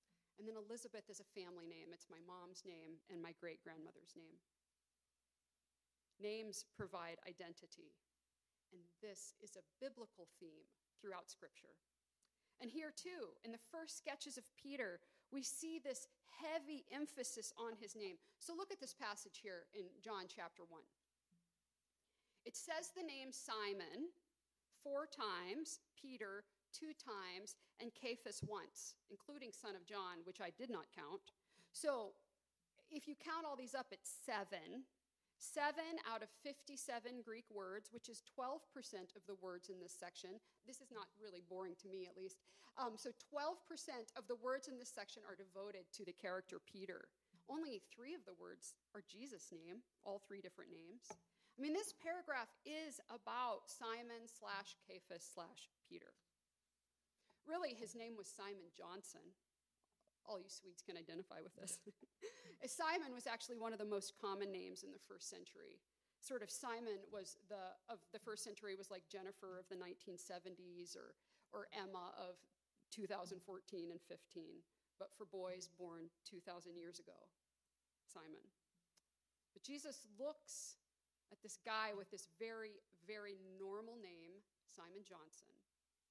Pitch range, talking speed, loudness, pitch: 185-260 Hz, 150 wpm, -52 LUFS, 205 Hz